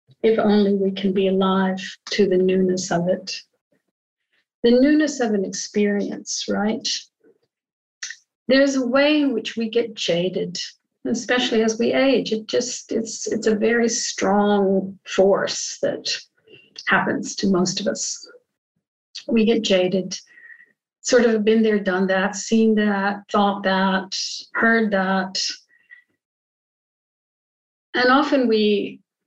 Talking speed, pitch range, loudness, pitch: 125 wpm, 195-245 Hz, -20 LUFS, 220 Hz